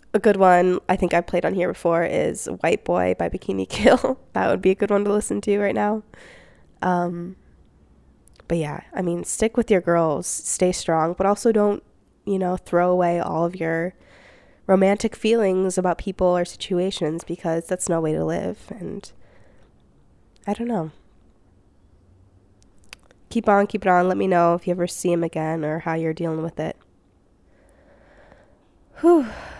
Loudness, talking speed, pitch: -22 LUFS, 170 wpm, 175 Hz